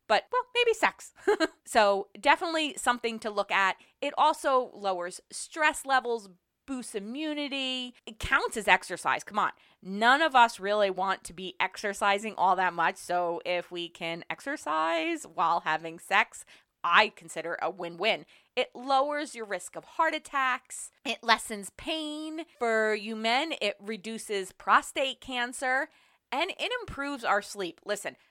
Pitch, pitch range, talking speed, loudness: 225 Hz, 190-285 Hz, 150 wpm, -29 LUFS